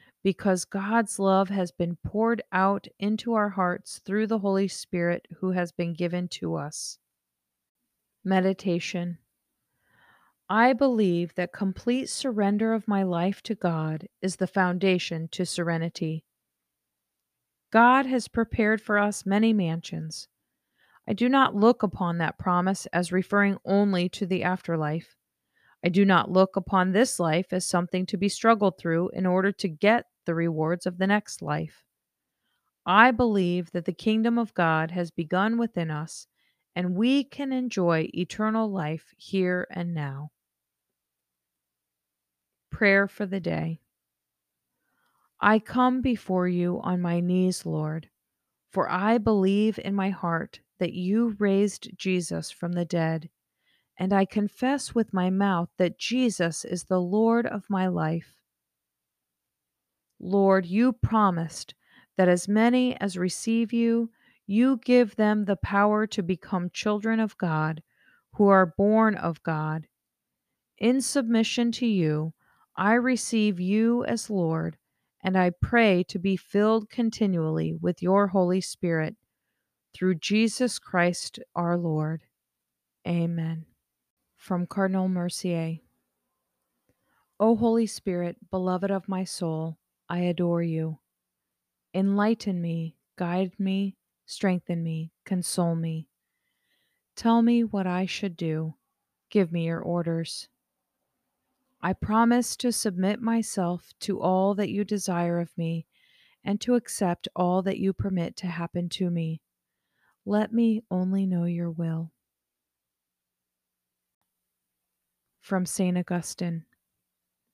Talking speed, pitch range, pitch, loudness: 130 wpm, 165-210 Hz, 185 Hz, -26 LUFS